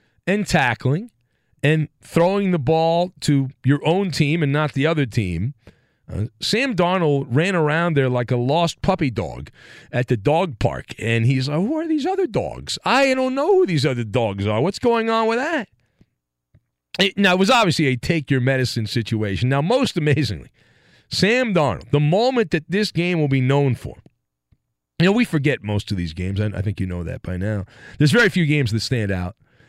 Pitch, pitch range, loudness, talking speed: 150 Hz, 120-180 Hz, -20 LUFS, 200 wpm